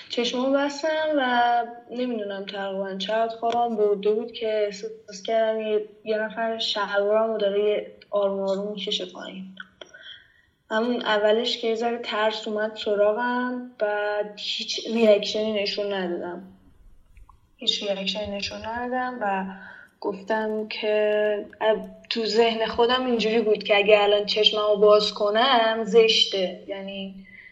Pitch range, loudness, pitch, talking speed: 205-230 Hz, -24 LUFS, 215 Hz, 120 wpm